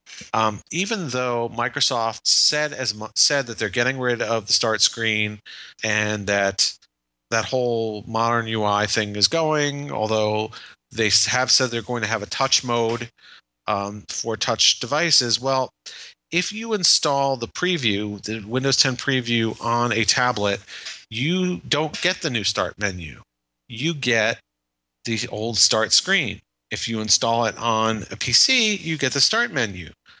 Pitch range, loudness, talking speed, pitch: 105-135 Hz, -21 LUFS, 155 wpm, 115 Hz